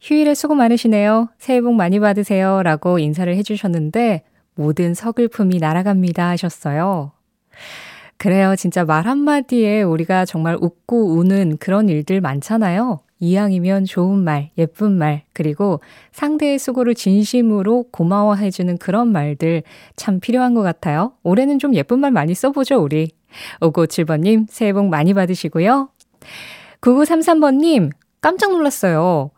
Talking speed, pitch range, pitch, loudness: 310 characters per minute, 170-235 Hz, 195 Hz, -16 LUFS